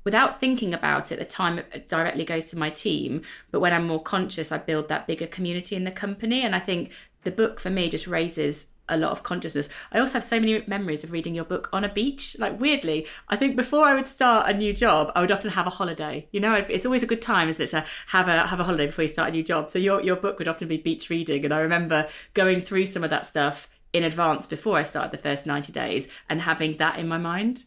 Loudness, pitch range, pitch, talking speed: -25 LUFS, 160-205 Hz, 175 Hz, 260 wpm